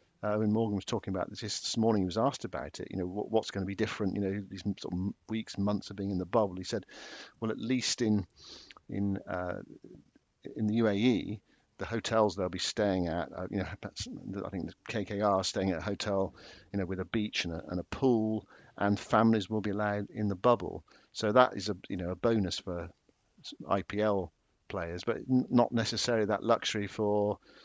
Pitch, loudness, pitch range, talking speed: 105 Hz, -32 LUFS, 95-110 Hz, 215 wpm